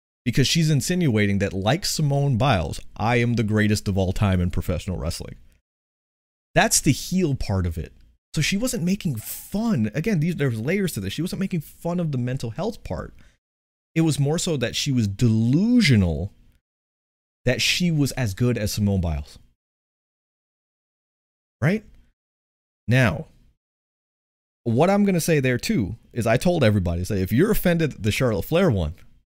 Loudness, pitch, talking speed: -22 LUFS, 120 Hz, 165 wpm